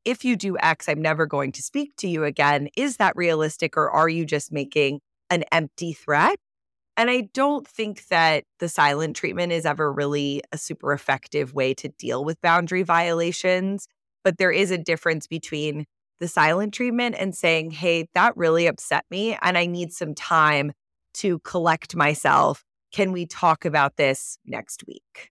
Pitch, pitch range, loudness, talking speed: 165 Hz, 150-180 Hz, -22 LUFS, 175 wpm